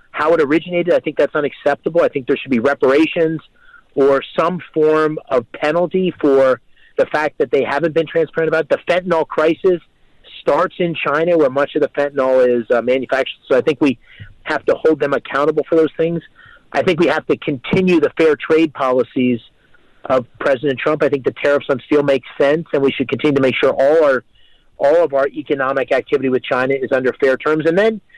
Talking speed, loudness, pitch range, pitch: 205 wpm, -16 LUFS, 135-175 Hz, 155 Hz